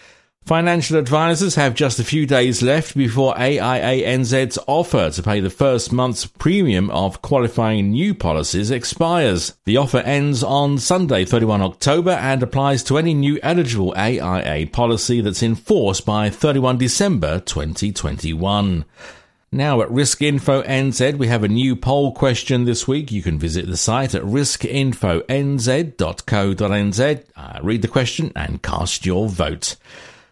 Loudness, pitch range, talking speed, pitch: -18 LUFS, 100-140 Hz, 145 wpm, 125 Hz